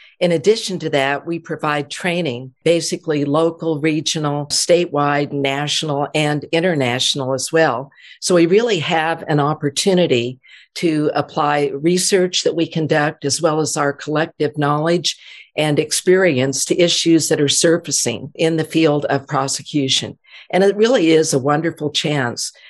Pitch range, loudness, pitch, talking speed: 145-165 Hz, -17 LUFS, 155 Hz, 140 wpm